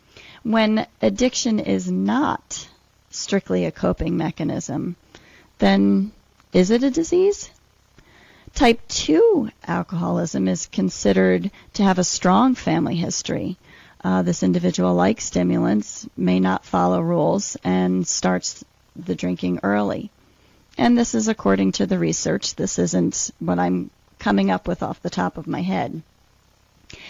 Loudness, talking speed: -21 LUFS, 130 wpm